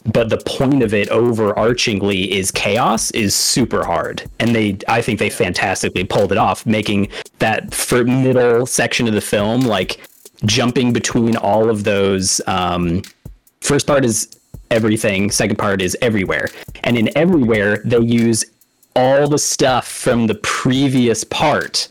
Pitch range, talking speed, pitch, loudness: 100-120 Hz, 150 wpm, 110 Hz, -16 LUFS